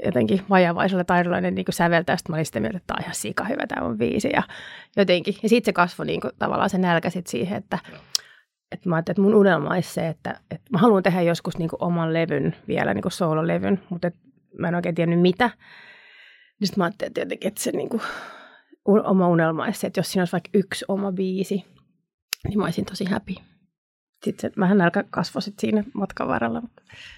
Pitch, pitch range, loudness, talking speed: 190 Hz, 175-205 Hz, -23 LUFS, 215 wpm